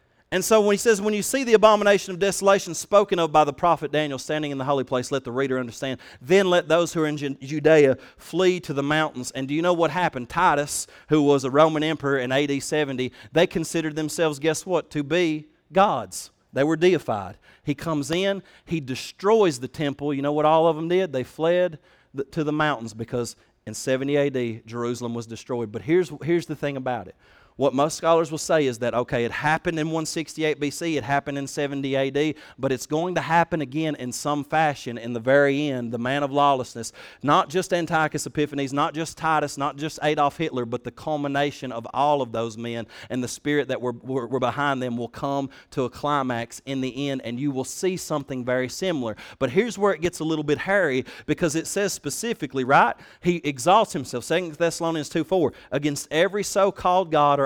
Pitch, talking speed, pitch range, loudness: 145 Hz, 210 wpm, 135-165 Hz, -23 LUFS